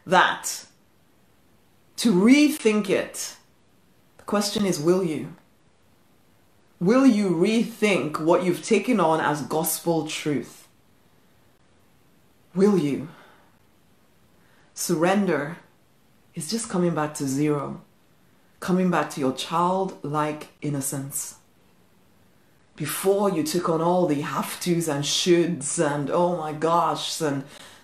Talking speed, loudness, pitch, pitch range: 105 wpm, -23 LUFS, 170 Hz, 150-190 Hz